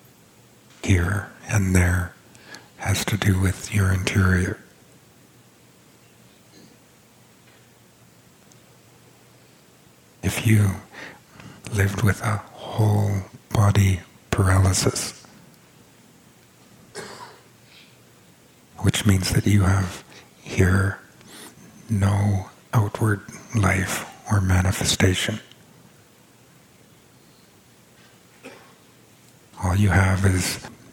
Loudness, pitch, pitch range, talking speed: -22 LUFS, 100 Hz, 95-105 Hz, 60 wpm